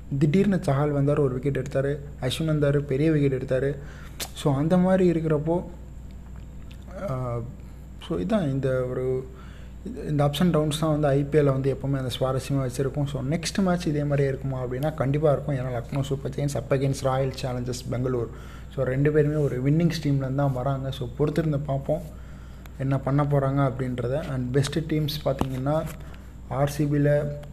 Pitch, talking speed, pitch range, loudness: 140 Hz, 150 wpm, 130-150 Hz, -25 LUFS